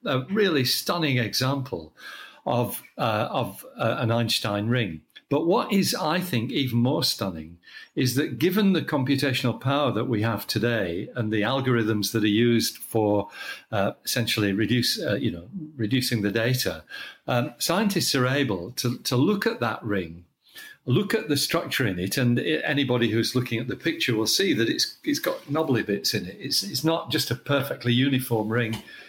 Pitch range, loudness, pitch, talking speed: 110-140 Hz, -25 LUFS, 125 Hz, 180 wpm